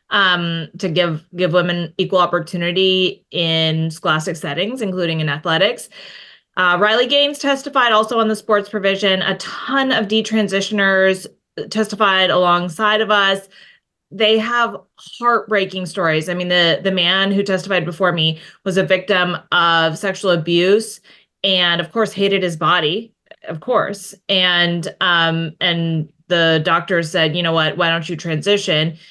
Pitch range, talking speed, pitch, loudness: 170-205 Hz, 145 wpm, 185 Hz, -16 LUFS